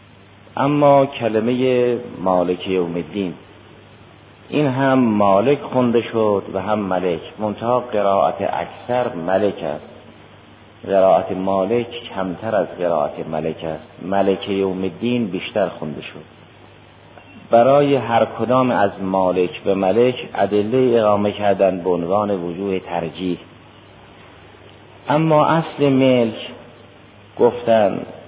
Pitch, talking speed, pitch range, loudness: 100 Hz, 105 wpm, 95-120 Hz, -18 LUFS